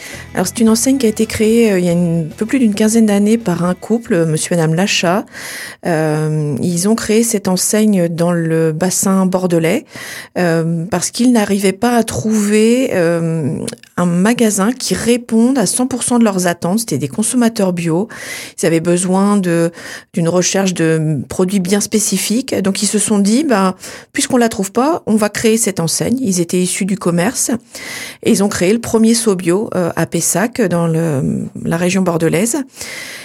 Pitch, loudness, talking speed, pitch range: 195 Hz, -14 LUFS, 180 wpm, 175-225 Hz